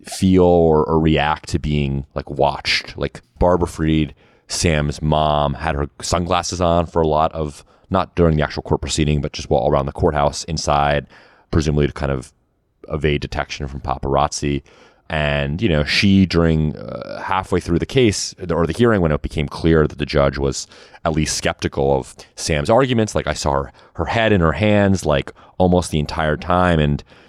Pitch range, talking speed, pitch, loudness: 75-85 Hz, 185 wpm, 80 Hz, -18 LUFS